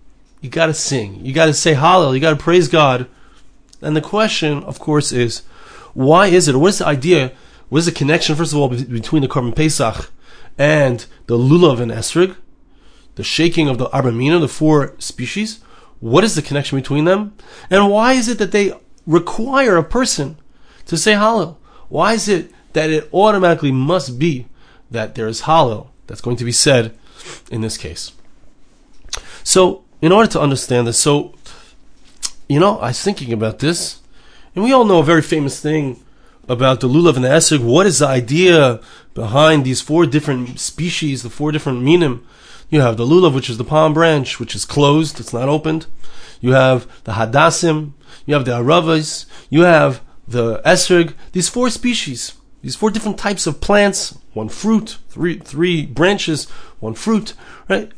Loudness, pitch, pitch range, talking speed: -15 LUFS, 155 Hz, 130-175 Hz, 175 wpm